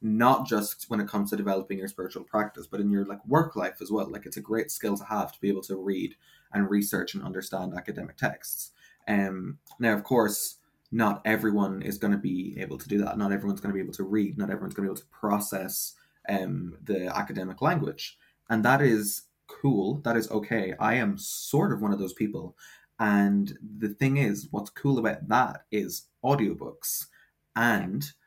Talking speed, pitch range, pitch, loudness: 205 wpm, 100-110 Hz, 105 Hz, -28 LUFS